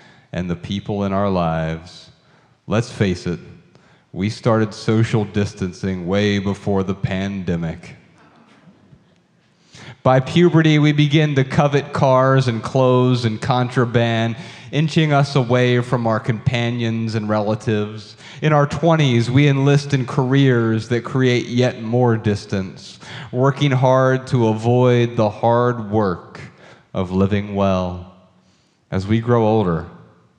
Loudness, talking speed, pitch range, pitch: -18 LUFS, 120 wpm, 100-130 Hz, 115 Hz